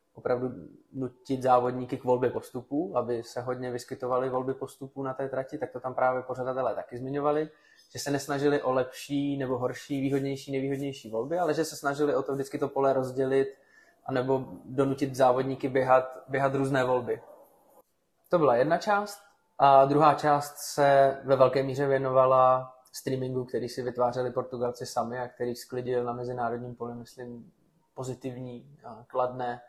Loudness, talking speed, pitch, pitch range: -28 LUFS, 160 wpm, 130 Hz, 125-140 Hz